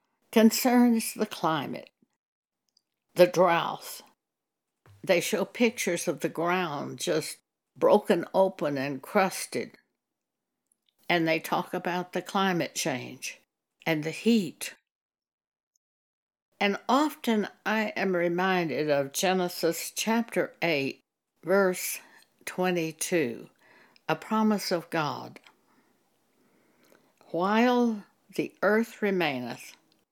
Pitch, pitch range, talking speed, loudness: 185 Hz, 170-220 Hz, 90 wpm, -27 LUFS